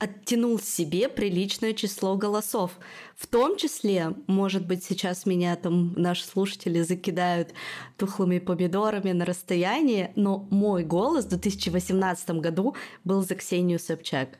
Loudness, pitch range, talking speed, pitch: -26 LUFS, 180-205 Hz, 125 wpm, 190 Hz